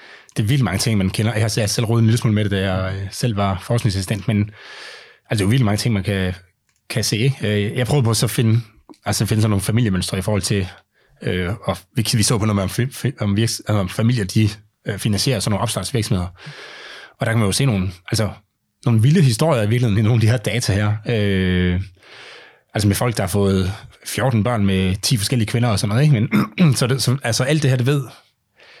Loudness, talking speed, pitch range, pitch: -19 LUFS, 220 wpm, 100-120 Hz, 110 Hz